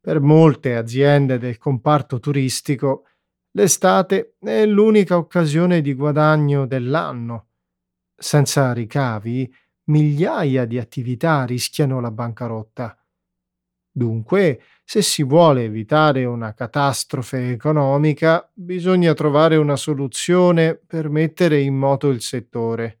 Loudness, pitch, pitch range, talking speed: -18 LUFS, 140 Hz, 125-160 Hz, 100 wpm